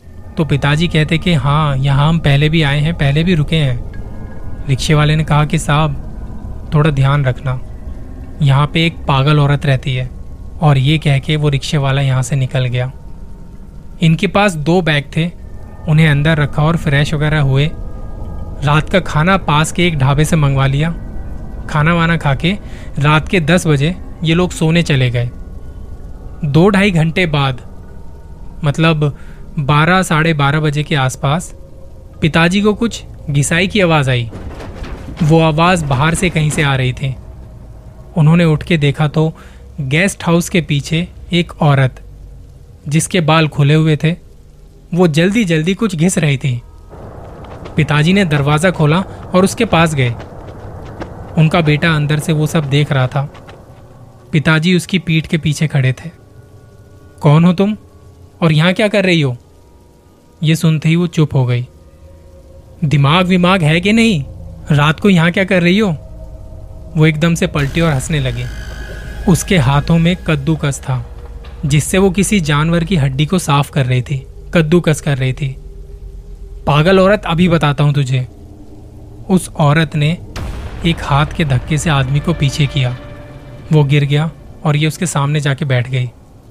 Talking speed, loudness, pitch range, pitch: 160 wpm, -13 LUFS, 125-165 Hz, 150 Hz